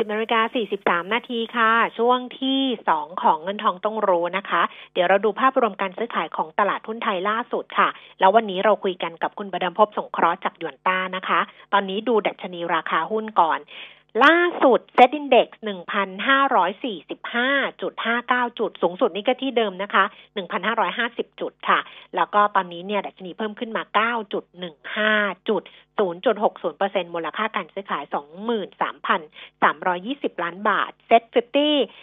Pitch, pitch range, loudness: 210 Hz, 190-235 Hz, -22 LUFS